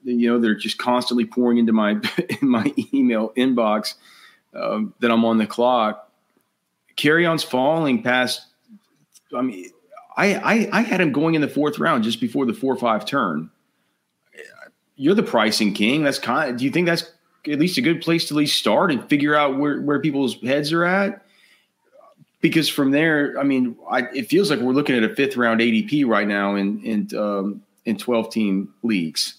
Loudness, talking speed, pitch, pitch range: -20 LUFS, 195 wpm, 135 Hz, 115-165 Hz